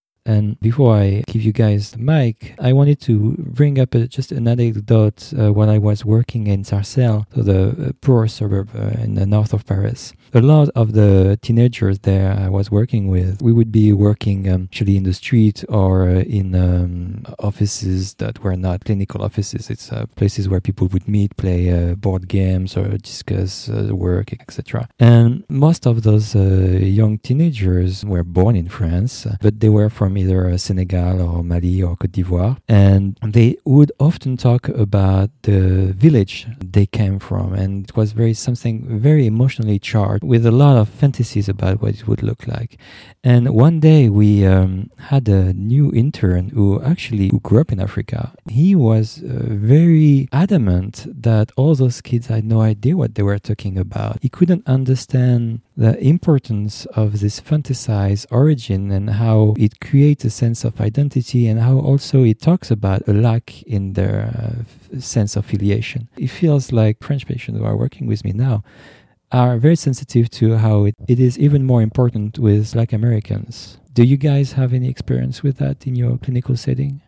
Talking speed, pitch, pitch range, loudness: 180 wpm, 110 Hz, 100-125 Hz, -16 LUFS